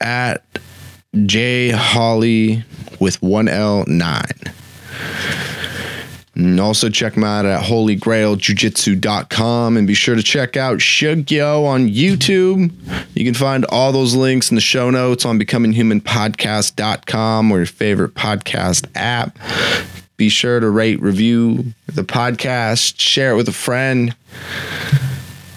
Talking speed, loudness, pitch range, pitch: 115 wpm, -15 LUFS, 110-130 Hz, 115 Hz